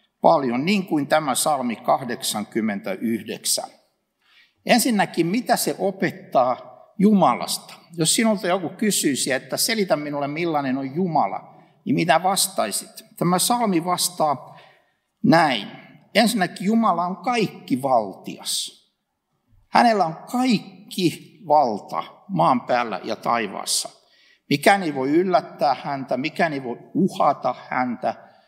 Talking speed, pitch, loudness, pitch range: 105 wpm, 190 Hz, -21 LUFS, 165-225 Hz